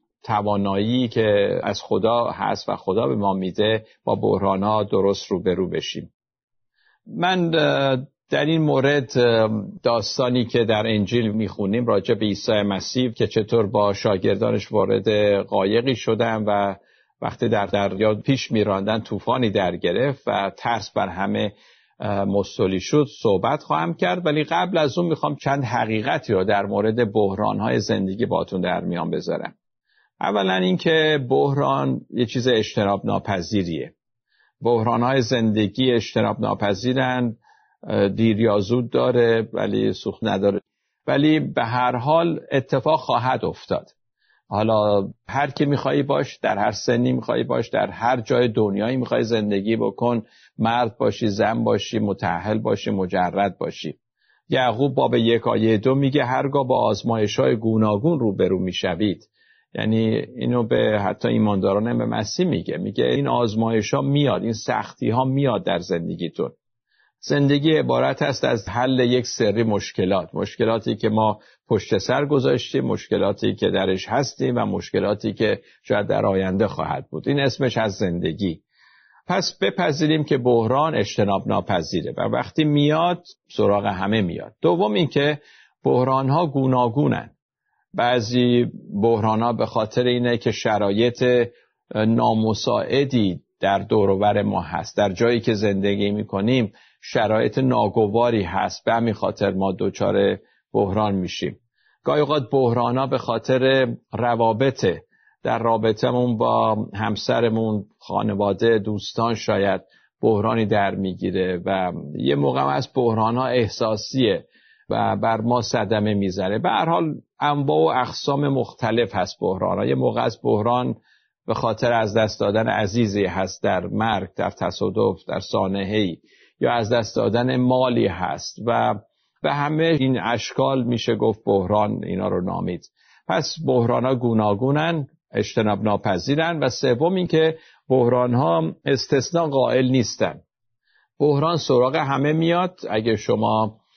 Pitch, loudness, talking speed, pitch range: 115 Hz, -21 LUFS, 135 wpm, 105-130 Hz